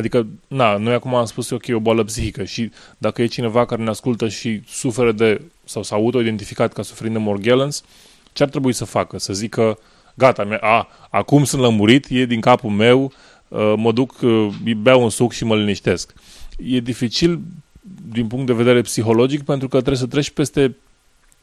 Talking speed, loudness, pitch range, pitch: 195 wpm, -18 LUFS, 110-130 Hz, 120 Hz